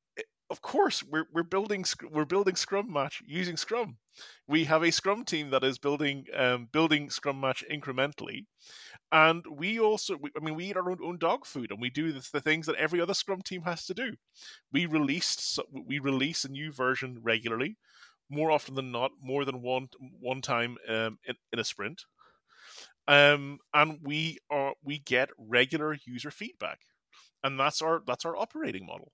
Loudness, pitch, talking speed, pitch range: -30 LUFS, 150 Hz, 185 wpm, 135-170 Hz